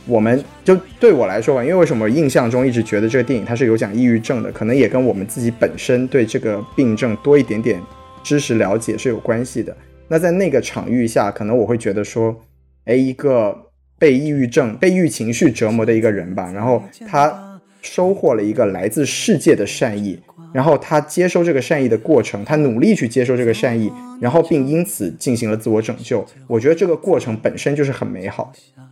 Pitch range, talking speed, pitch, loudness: 110-145 Hz, 325 characters per minute, 125 Hz, -17 LUFS